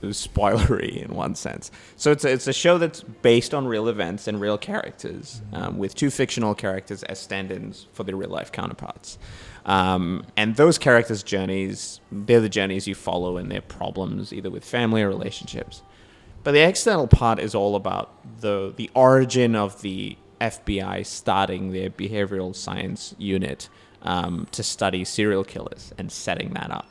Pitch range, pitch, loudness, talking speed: 95-120 Hz, 105 Hz, -23 LUFS, 170 wpm